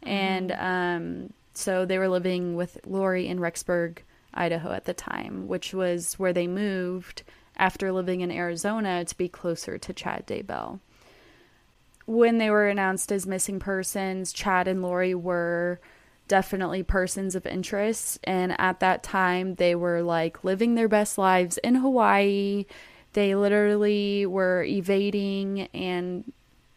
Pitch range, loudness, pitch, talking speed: 180-200 Hz, -26 LUFS, 185 Hz, 140 wpm